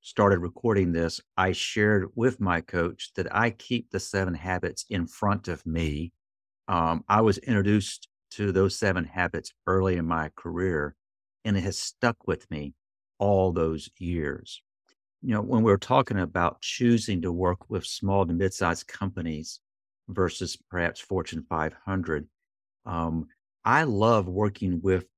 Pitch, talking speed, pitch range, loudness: 95 Hz, 150 wpm, 85-100 Hz, -27 LUFS